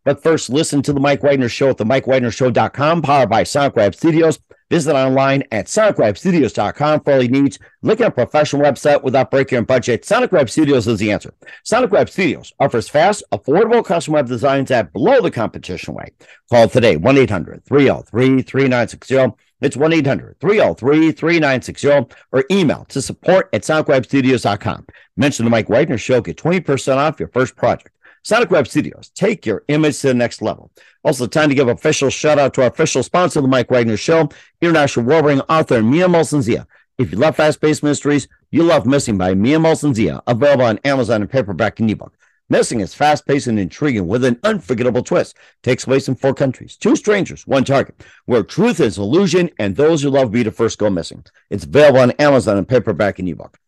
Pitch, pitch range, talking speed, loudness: 135 Hz, 120-150 Hz, 185 wpm, -15 LUFS